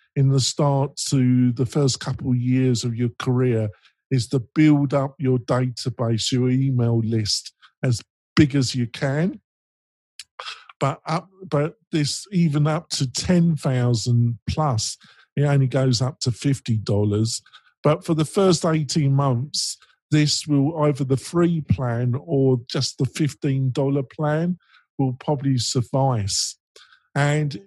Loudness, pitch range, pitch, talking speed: -22 LUFS, 125-150 Hz, 135 Hz, 140 wpm